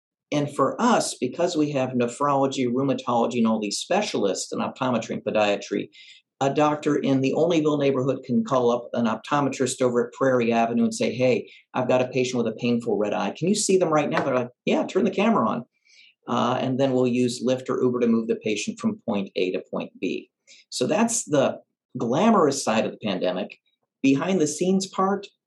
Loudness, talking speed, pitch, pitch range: -24 LUFS, 205 wpm, 130 Hz, 120-150 Hz